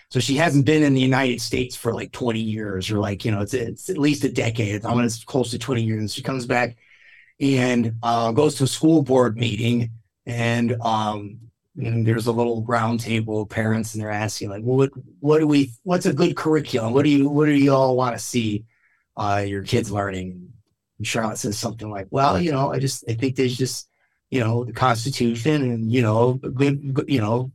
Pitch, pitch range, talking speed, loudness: 120 Hz, 110-135 Hz, 225 wpm, -21 LUFS